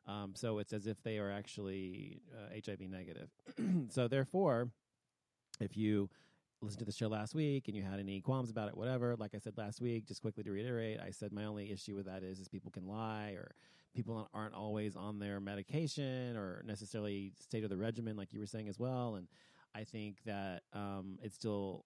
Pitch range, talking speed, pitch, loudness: 100-115 Hz, 215 wpm, 105 Hz, -43 LUFS